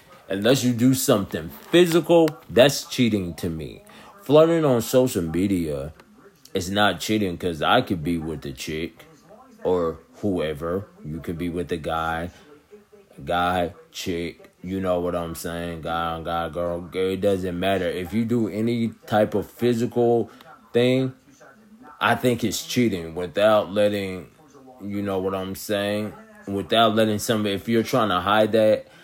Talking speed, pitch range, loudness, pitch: 150 wpm, 90-120 Hz, -23 LUFS, 105 Hz